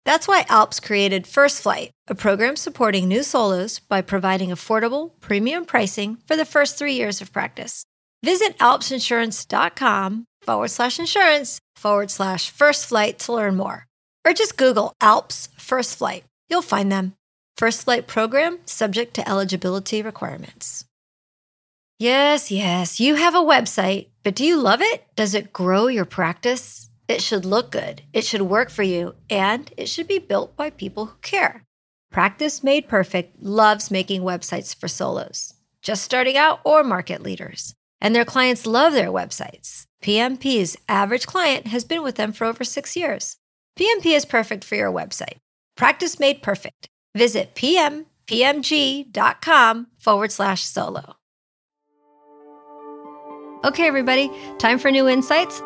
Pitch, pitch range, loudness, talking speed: 225 Hz, 195-280 Hz, -20 LUFS, 145 wpm